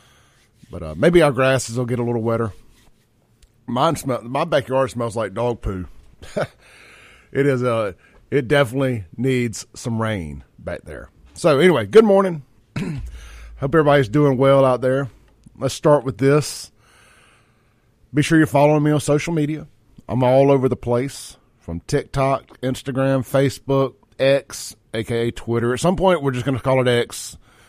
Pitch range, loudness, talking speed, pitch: 115-140 Hz, -19 LUFS, 155 wpm, 130 Hz